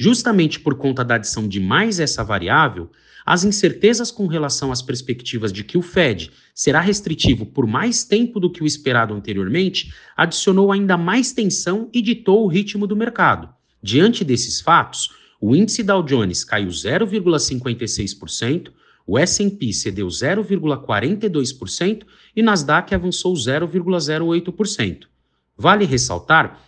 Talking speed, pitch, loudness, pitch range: 130 wpm, 170 Hz, -18 LUFS, 120-200 Hz